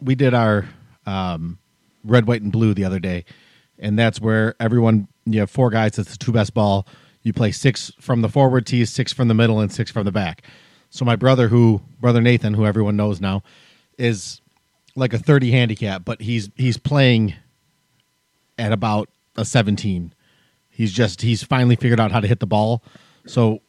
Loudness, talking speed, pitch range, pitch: -19 LUFS, 190 wpm, 105-125 Hz, 115 Hz